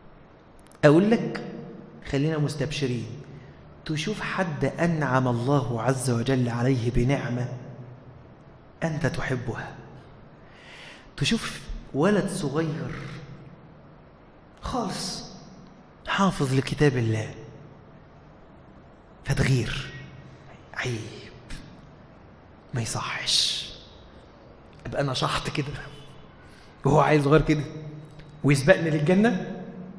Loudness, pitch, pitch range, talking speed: -25 LUFS, 145 Hz, 130-160 Hz, 70 wpm